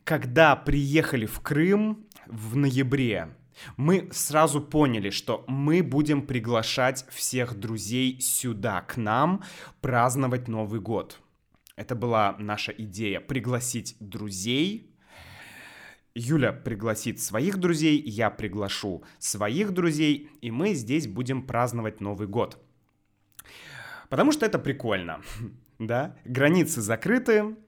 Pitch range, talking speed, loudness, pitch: 115-155 Hz, 105 wpm, -26 LUFS, 125 Hz